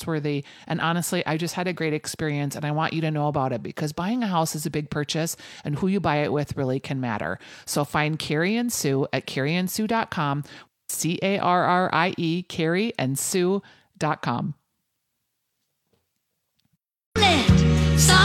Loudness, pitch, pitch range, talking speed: -24 LUFS, 160 Hz, 145-180 Hz, 145 wpm